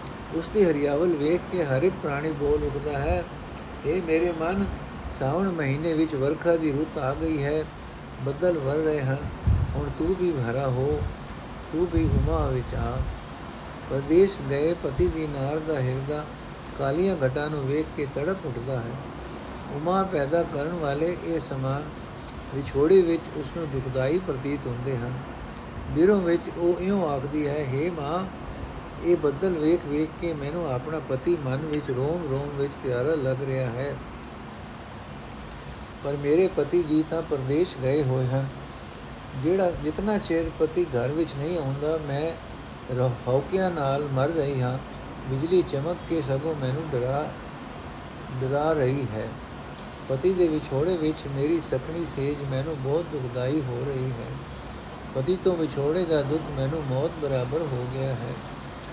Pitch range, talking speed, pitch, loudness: 130-165 Hz, 145 wpm, 145 Hz, -27 LUFS